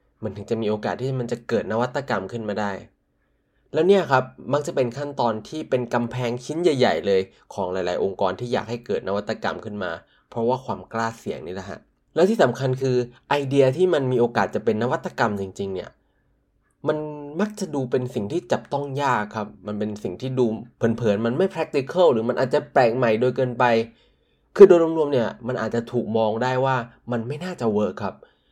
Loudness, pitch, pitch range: -23 LUFS, 125 Hz, 110-140 Hz